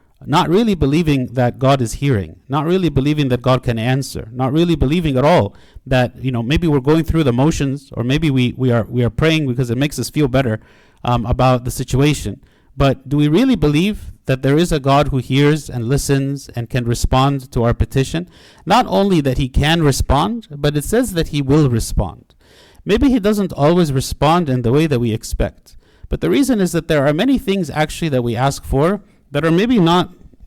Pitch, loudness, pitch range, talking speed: 140 Hz, -16 LUFS, 125-160 Hz, 215 wpm